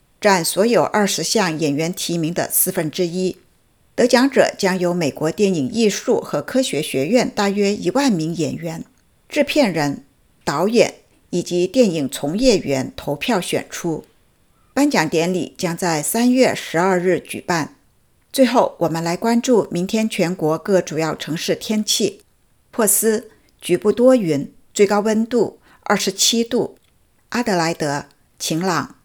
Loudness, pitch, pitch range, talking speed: -18 LUFS, 195 Hz, 170-230 Hz, 215 characters per minute